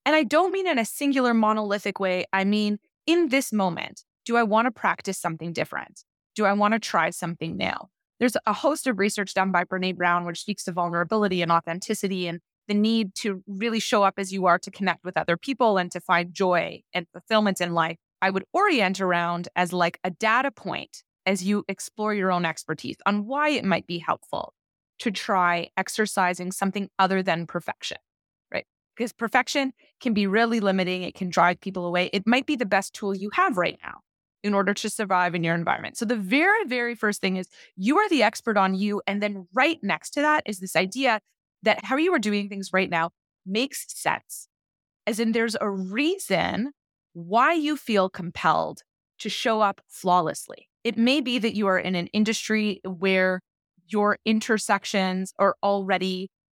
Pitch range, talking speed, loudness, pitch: 185-230 Hz, 190 wpm, -24 LUFS, 200 Hz